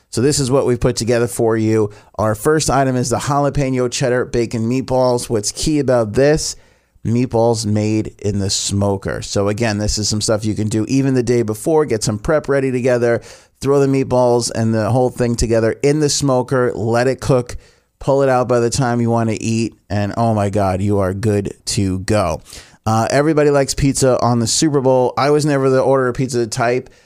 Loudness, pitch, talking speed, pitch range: -16 LUFS, 120 Hz, 210 wpm, 110-135 Hz